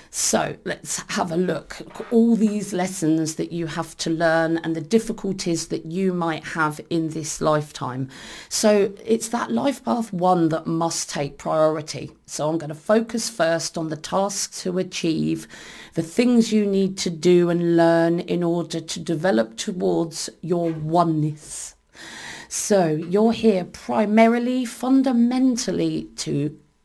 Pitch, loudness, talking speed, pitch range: 170 Hz, -22 LUFS, 150 wpm, 160-210 Hz